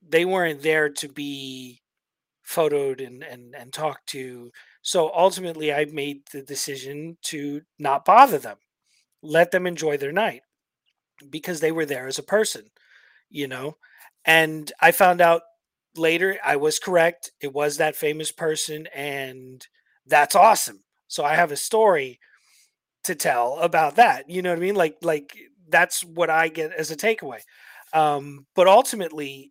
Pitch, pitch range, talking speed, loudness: 155 Hz, 140-170 Hz, 155 wpm, -21 LUFS